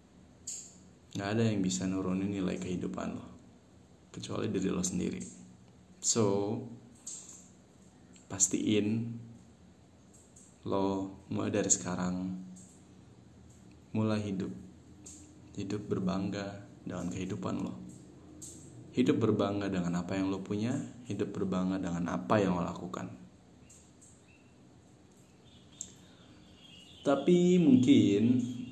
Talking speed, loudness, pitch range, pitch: 85 wpm, -32 LUFS, 80-105 Hz, 95 Hz